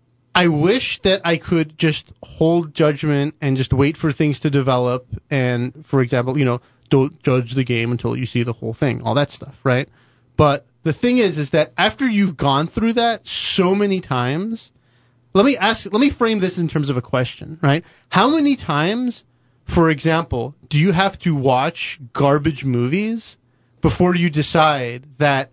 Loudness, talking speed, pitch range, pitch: -18 LUFS, 180 wpm, 125-175 Hz, 150 Hz